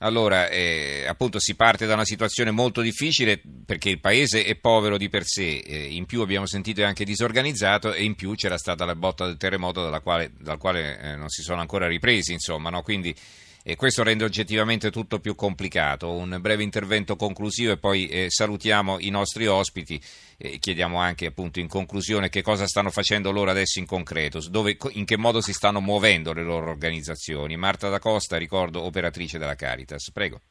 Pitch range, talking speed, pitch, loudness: 85-110 Hz, 190 wpm, 100 Hz, -24 LUFS